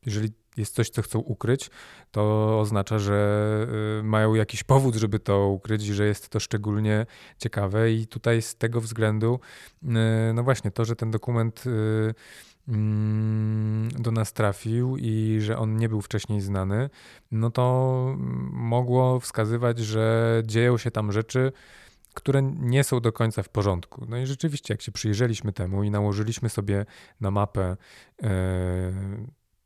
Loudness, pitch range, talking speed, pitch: -26 LUFS, 105-115 Hz, 140 wpm, 110 Hz